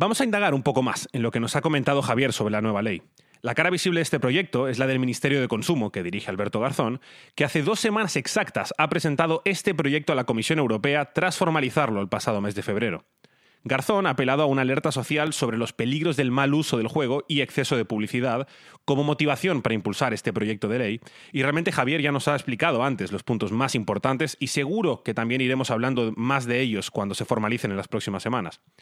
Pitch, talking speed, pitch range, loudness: 135 Hz, 225 wpm, 115-150 Hz, -24 LUFS